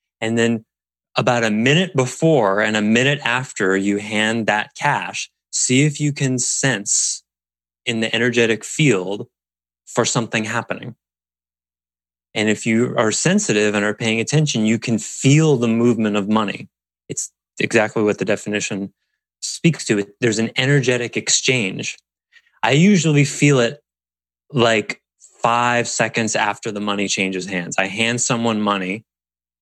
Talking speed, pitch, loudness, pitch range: 140 wpm, 110 Hz, -18 LUFS, 100-125 Hz